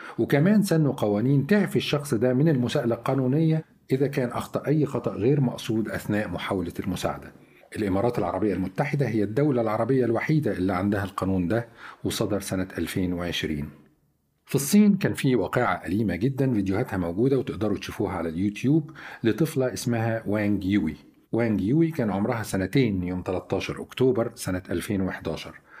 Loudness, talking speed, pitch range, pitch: -25 LUFS, 140 wpm, 95-135 Hz, 115 Hz